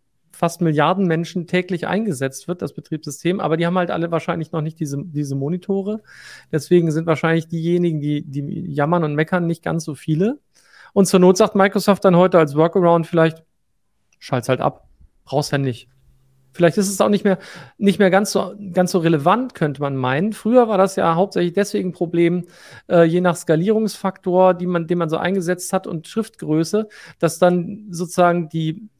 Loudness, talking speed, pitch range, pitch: -19 LUFS, 180 wpm, 160-190 Hz, 175 Hz